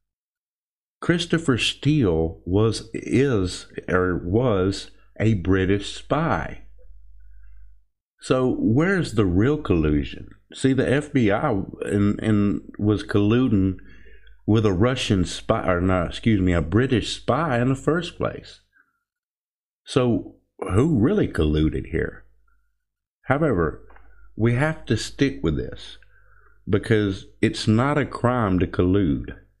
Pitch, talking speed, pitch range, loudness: 105 Hz, 110 wpm, 95-130 Hz, -22 LUFS